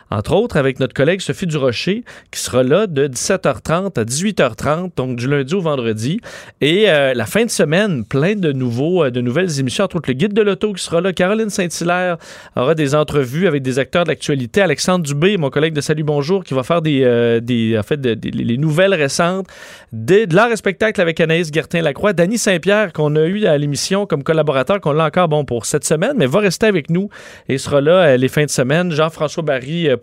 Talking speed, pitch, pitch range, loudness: 220 wpm, 160 Hz, 140-190 Hz, -16 LUFS